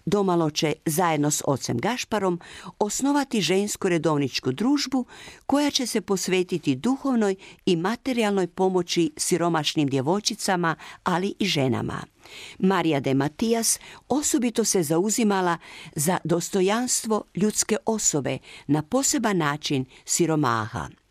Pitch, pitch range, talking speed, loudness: 185 Hz, 160-220 Hz, 105 wpm, -24 LUFS